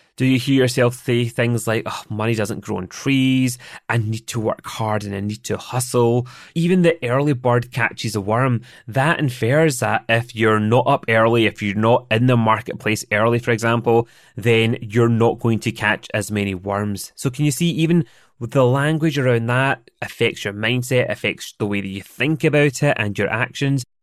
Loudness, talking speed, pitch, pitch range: -19 LUFS, 195 wpm, 120 Hz, 110-130 Hz